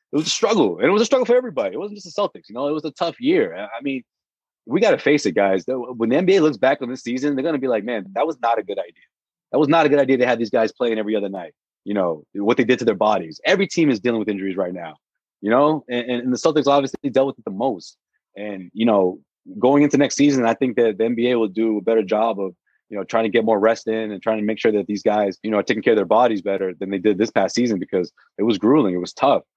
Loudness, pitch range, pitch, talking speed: -20 LUFS, 110-145 Hz, 120 Hz, 300 wpm